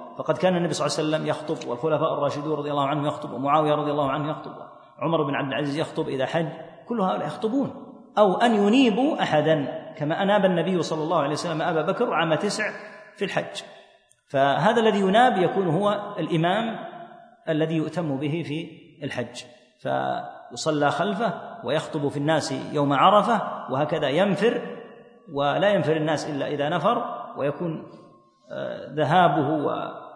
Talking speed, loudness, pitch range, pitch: 150 wpm, -24 LUFS, 150-205 Hz, 160 Hz